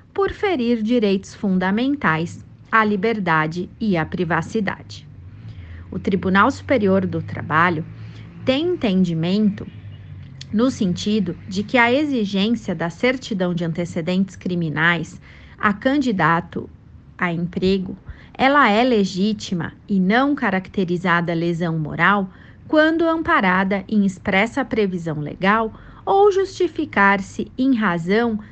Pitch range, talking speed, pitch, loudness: 170-235 Hz, 105 wpm, 195 Hz, -19 LUFS